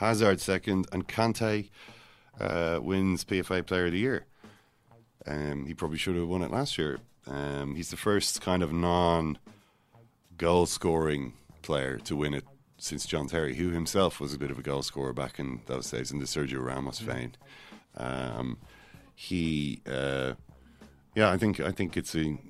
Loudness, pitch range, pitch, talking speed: -30 LUFS, 70-95 Hz, 85 Hz, 170 wpm